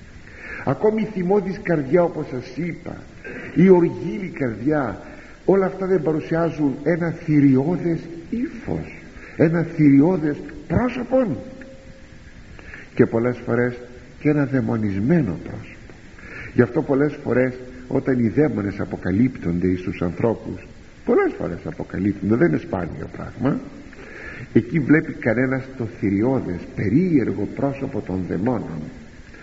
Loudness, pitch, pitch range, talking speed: -21 LUFS, 130 Hz, 105-165 Hz, 110 wpm